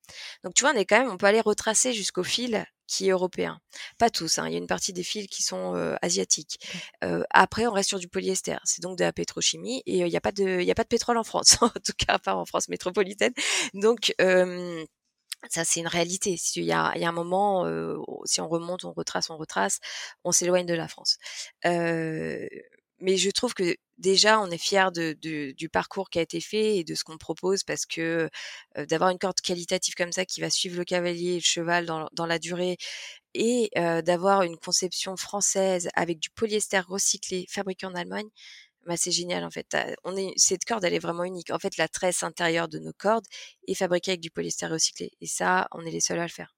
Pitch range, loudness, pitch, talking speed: 165-200 Hz, -26 LUFS, 180 Hz, 230 wpm